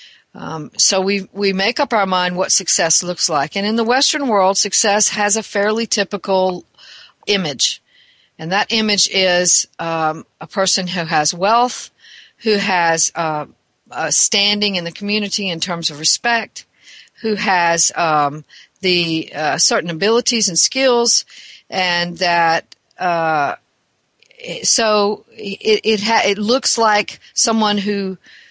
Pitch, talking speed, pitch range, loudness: 200 Hz, 140 wpm, 175-220 Hz, -15 LUFS